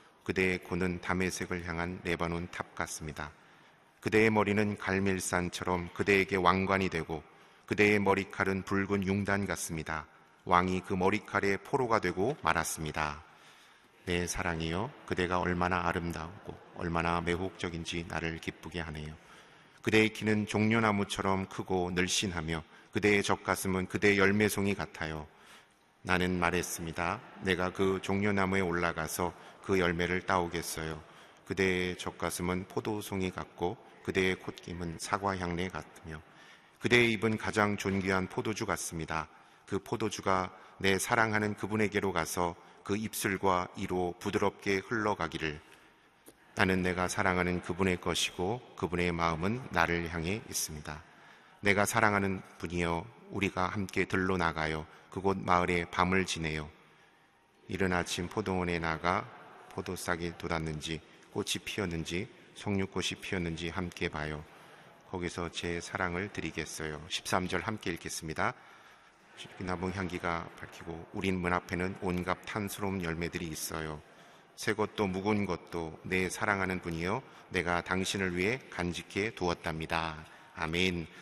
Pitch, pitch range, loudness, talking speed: 90 Hz, 85-100 Hz, -32 LUFS, 305 characters per minute